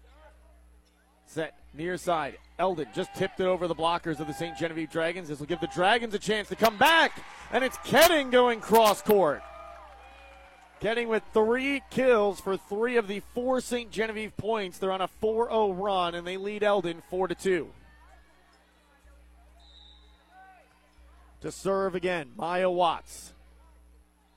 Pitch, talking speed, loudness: 180 Hz, 140 wpm, -27 LUFS